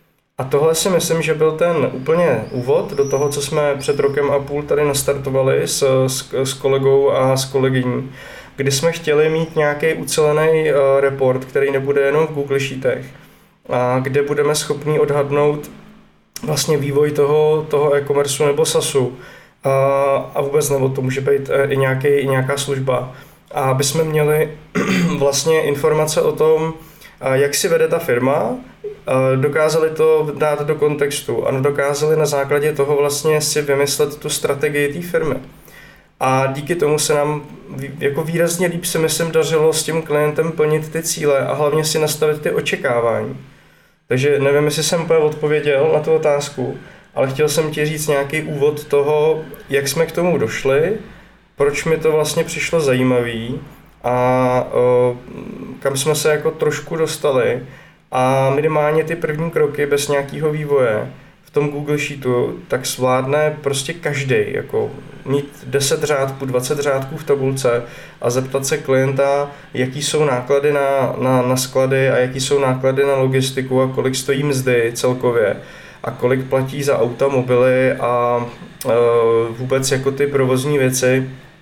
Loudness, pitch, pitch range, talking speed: -17 LUFS, 145 Hz, 135-155 Hz, 155 wpm